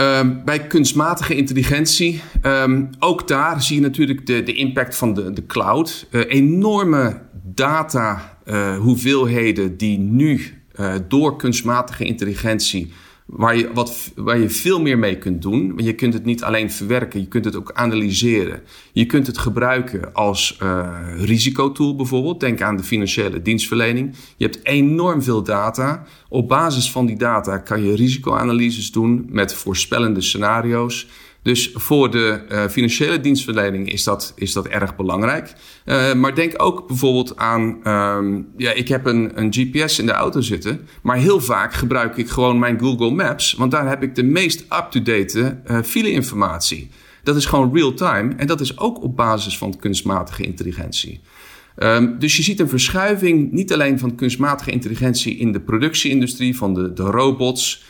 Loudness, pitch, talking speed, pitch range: -18 LUFS, 120 Hz, 165 wpm, 105-135 Hz